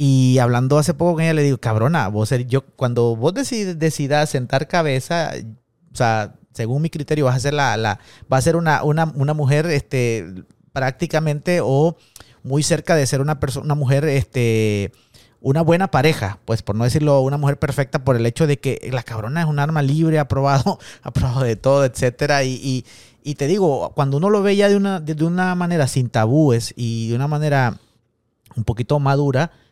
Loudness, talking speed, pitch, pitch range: -19 LUFS, 195 wpm, 140 Hz, 120-155 Hz